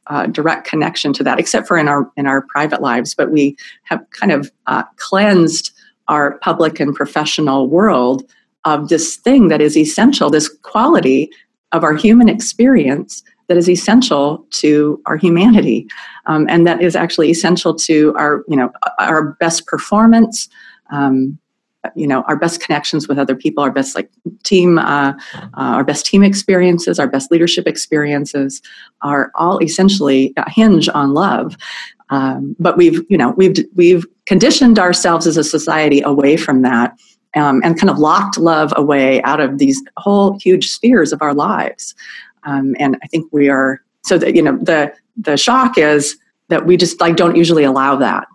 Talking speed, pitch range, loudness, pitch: 170 wpm, 145-185 Hz, -13 LUFS, 160 Hz